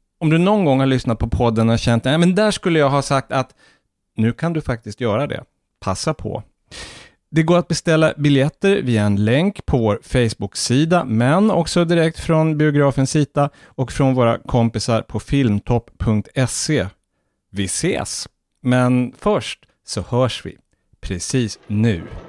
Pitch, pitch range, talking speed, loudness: 130 Hz, 115-155 Hz, 155 wpm, -18 LUFS